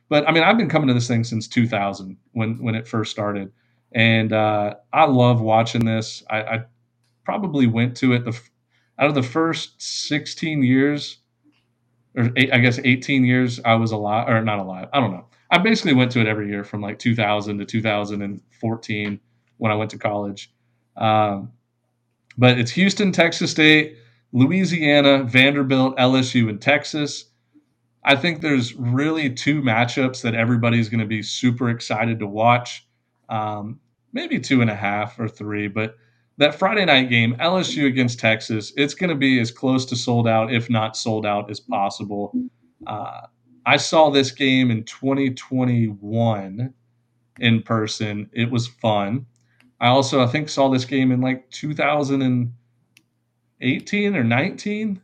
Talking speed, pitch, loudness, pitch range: 160 wpm, 120 Hz, -20 LUFS, 110-135 Hz